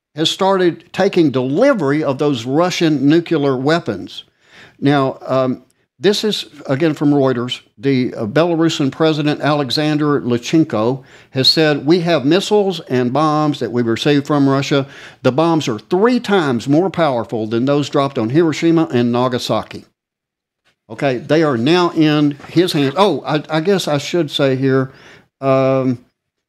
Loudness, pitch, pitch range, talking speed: -15 LUFS, 145 Hz, 130-165 Hz, 145 wpm